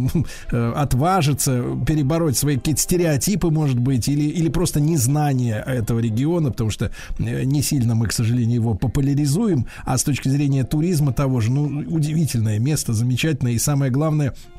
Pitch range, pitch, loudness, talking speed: 120-150 Hz, 140 Hz, -20 LUFS, 150 wpm